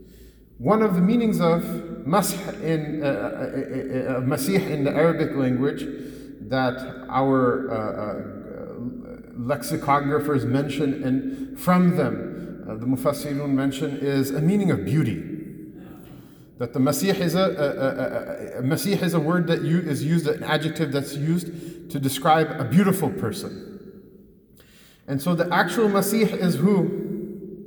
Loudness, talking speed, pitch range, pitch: -23 LUFS, 140 wpm, 140-190 Hz, 155 Hz